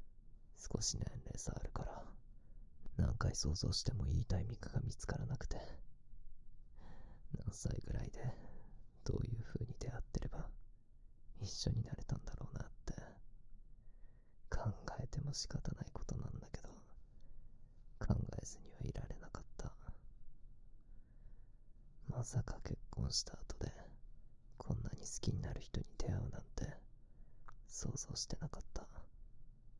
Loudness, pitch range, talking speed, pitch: -45 LUFS, 110-130 Hz, 250 characters per minute, 115 Hz